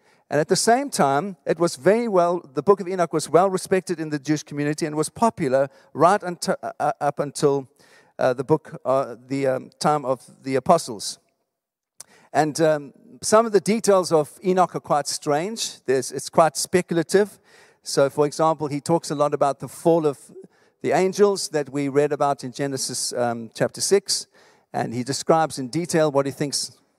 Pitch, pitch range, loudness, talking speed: 155 Hz, 140-180 Hz, -22 LUFS, 185 wpm